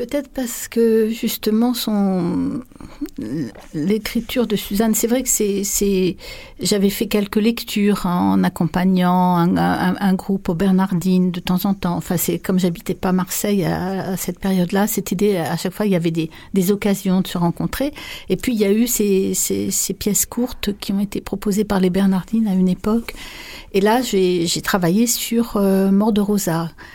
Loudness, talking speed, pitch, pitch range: -19 LUFS, 190 wpm, 200 Hz, 185-220 Hz